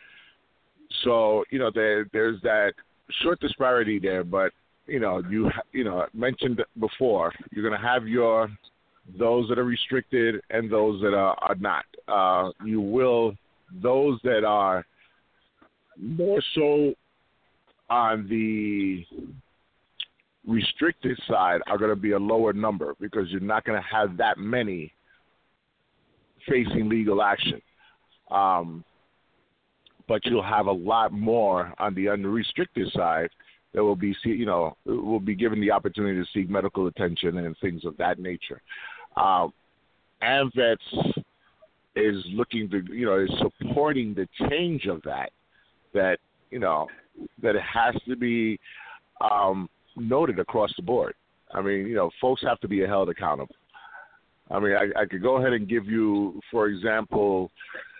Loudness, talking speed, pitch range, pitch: -25 LUFS, 145 wpm, 100-120 Hz, 110 Hz